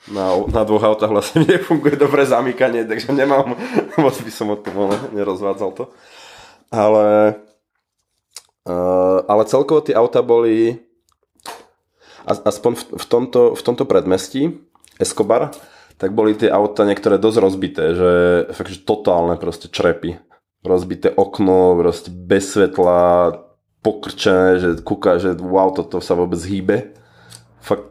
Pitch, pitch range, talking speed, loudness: 105 Hz, 90-115 Hz, 130 wpm, -16 LUFS